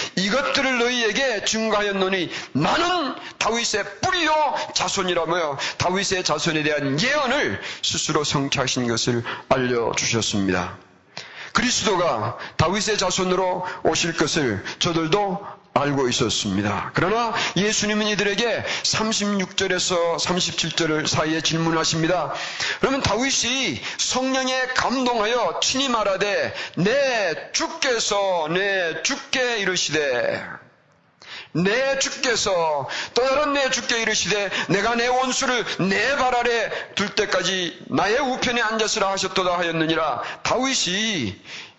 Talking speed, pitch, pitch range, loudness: 265 characters per minute, 200 Hz, 165-245 Hz, -21 LUFS